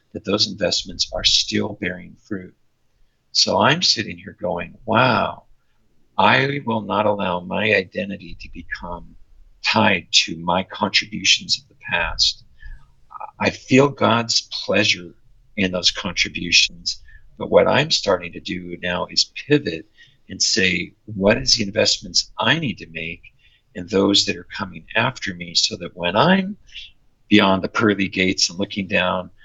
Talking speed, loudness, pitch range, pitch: 145 wpm, -19 LUFS, 90-110 Hz, 100 Hz